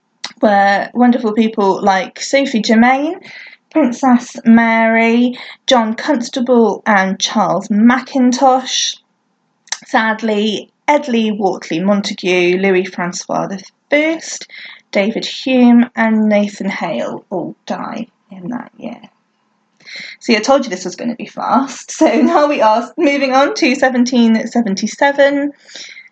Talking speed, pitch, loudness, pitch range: 110 wpm, 230 Hz, -14 LUFS, 205-260 Hz